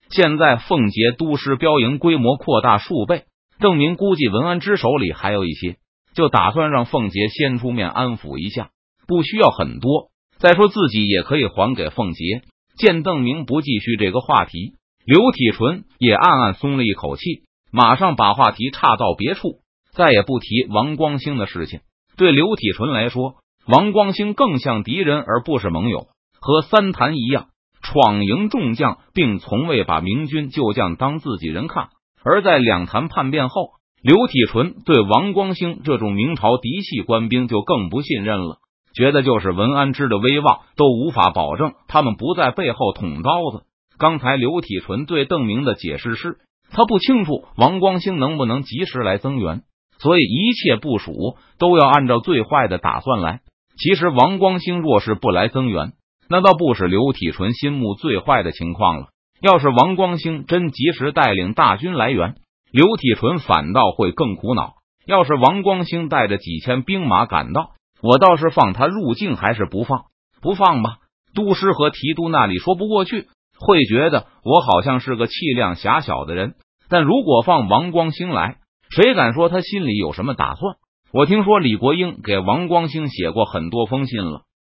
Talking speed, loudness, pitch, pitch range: 260 characters per minute, -17 LUFS, 140 Hz, 115-175 Hz